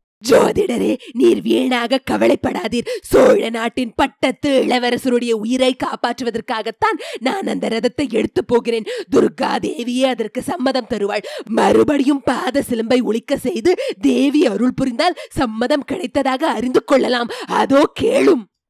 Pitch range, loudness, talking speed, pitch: 240-290 Hz, -17 LUFS, 110 wpm, 260 Hz